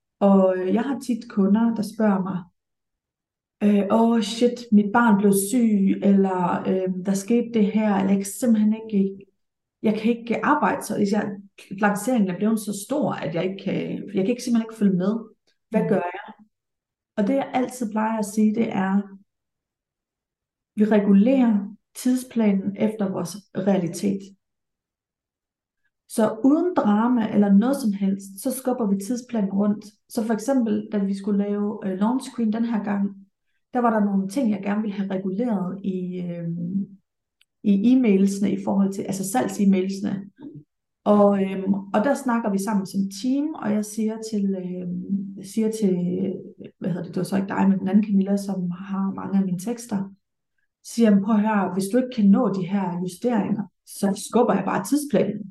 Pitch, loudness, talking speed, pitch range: 205 Hz, -23 LUFS, 170 wpm, 195-225 Hz